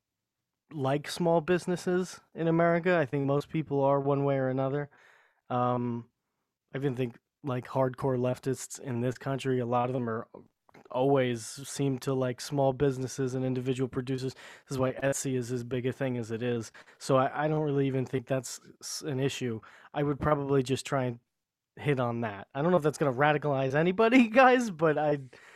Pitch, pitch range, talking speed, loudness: 135 Hz, 130-145 Hz, 190 wpm, -29 LUFS